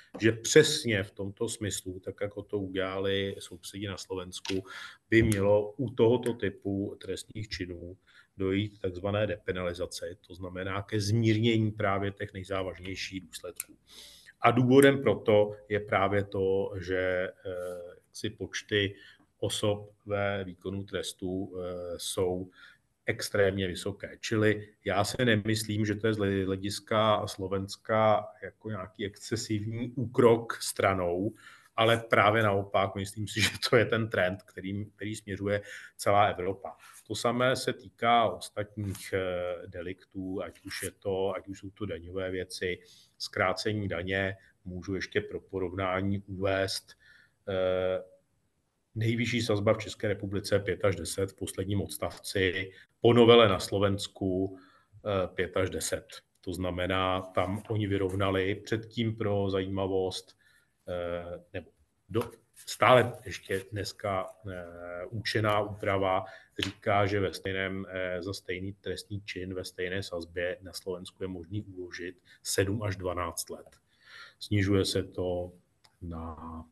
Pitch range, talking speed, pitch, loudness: 95-105 Hz, 120 wpm, 100 Hz, -30 LUFS